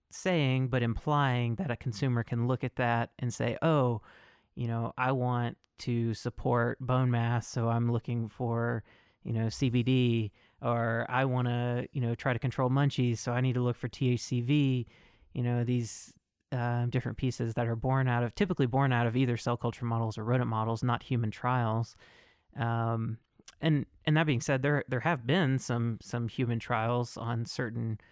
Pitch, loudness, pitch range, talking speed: 120 Hz, -31 LUFS, 115-130 Hz, 185 wpm